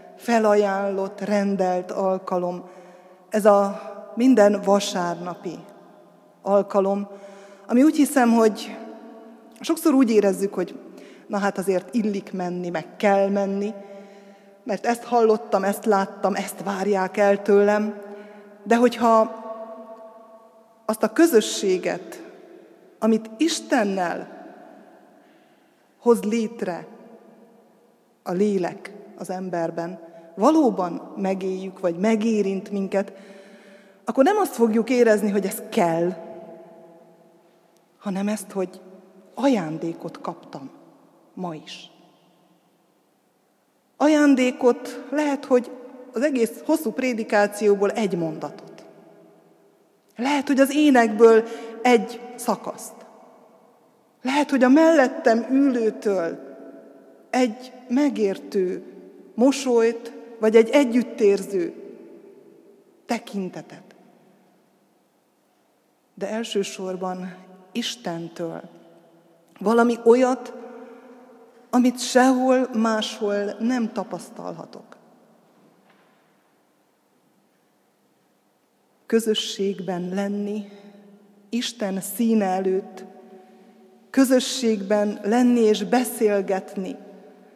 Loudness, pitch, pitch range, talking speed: -22 LUFS, 210 Hz, 195-235 Hz, 75 wpm